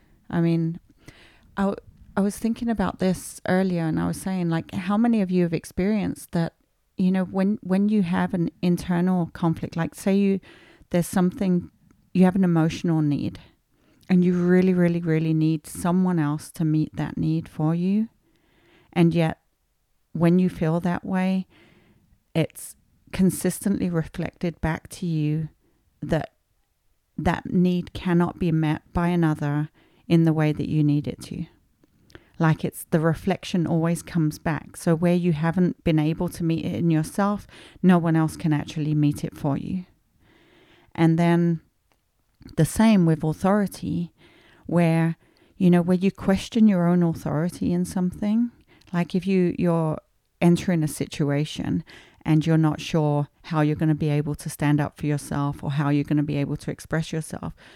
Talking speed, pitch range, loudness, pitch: 165 wpm, 155-185 Hz, -24 LUFS, 170 Hz